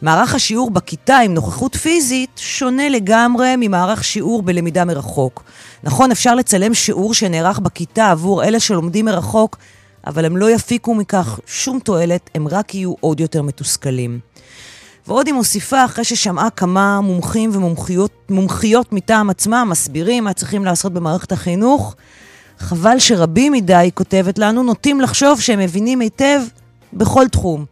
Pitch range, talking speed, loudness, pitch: 170-235 Hz, 140 wpm, -15 LUFS, 200 Hz